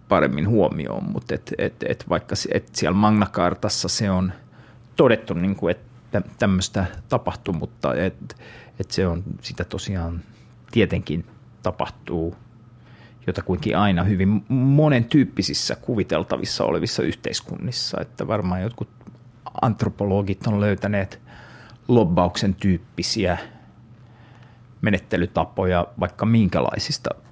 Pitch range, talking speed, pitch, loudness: 95-115 Hz, 95 wpm, 105 Hz, -23 LUFS